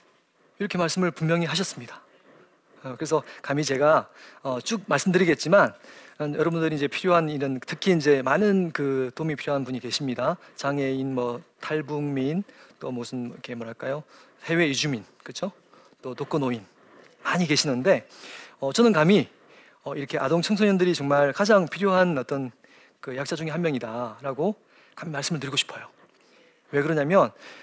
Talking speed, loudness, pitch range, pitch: 315 characters per minute, -25 LUFS, 135-175 Hz, 150 Hz